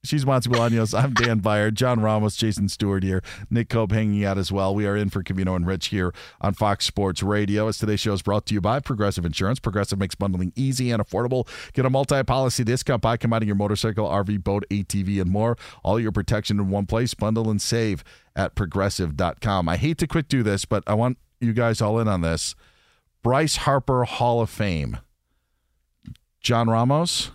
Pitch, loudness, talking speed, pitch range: 105 Hz, -23 LUFS, 200 wpm, 100-120 Hz